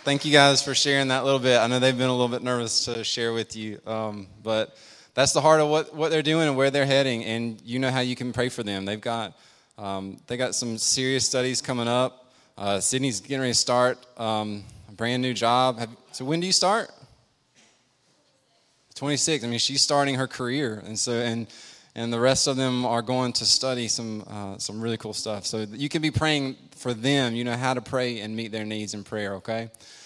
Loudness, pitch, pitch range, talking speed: -24 LUFS, 125 Hz, 110-135 Hz, 230 wpm